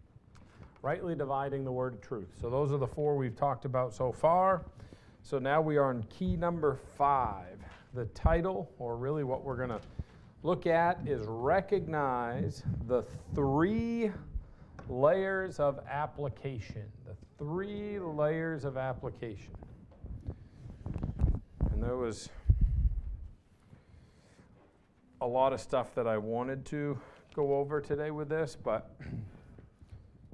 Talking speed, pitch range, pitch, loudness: 125 wpm, 110-150 Hz, 135 Hz, -33 LUFS